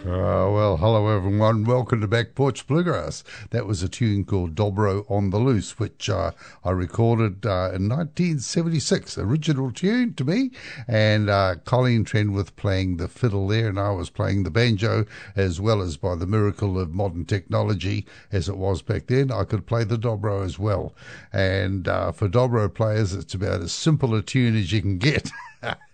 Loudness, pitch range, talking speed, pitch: -23 LUFS, 95-120 Hz, 185 wpm, 105 Hz